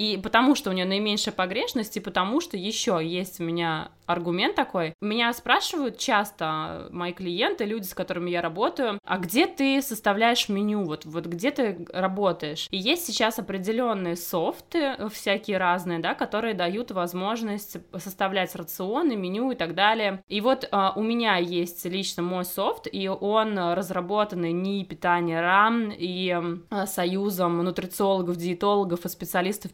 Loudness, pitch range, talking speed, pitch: -26 LUFS, 175-220 Hz, 150 wpm, 195 Hz